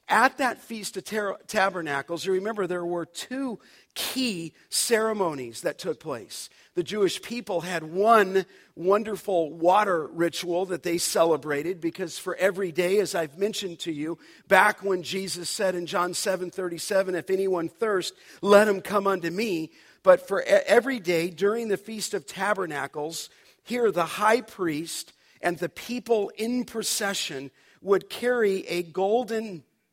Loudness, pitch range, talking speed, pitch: -26 LUFS, 170-210 Hz, 150 wpm, 190 Hz